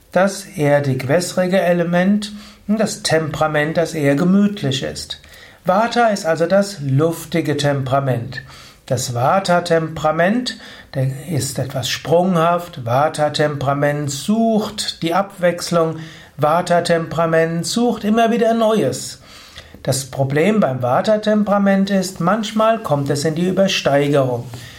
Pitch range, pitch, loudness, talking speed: 140-195 Hz, 165 Hz, -17 LUFS, 105 wpm